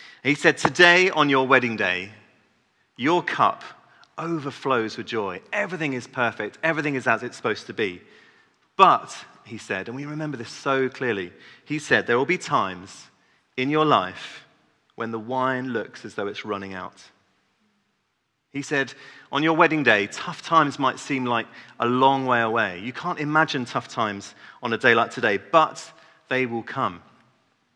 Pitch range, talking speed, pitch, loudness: 120-155 Hz, 170 wpm, 135 Hz, -22 LUFS